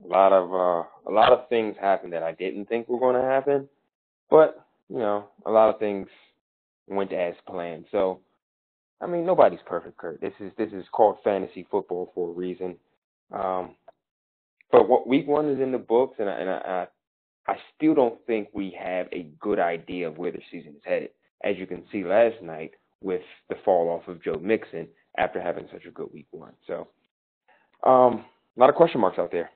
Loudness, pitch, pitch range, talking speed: -24 LUFS, 100 Hz, 90-120 Hz, 205 wpm